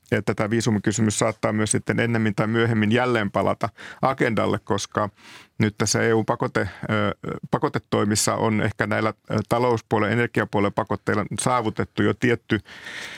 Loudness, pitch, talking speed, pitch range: -23 LUFS, 110 Hz, 115 wpm, 105-115 Hz